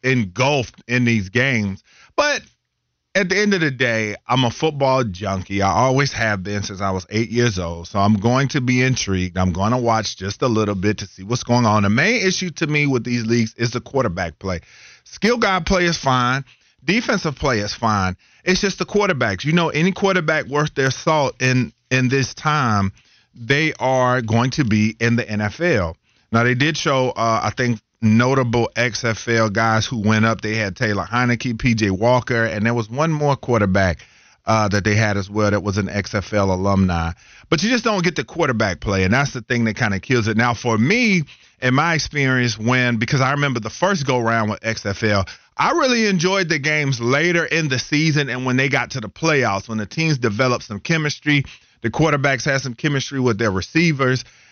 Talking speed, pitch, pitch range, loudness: 205 wpm, 120 Hz, 105-145 Hz, -19 LUFS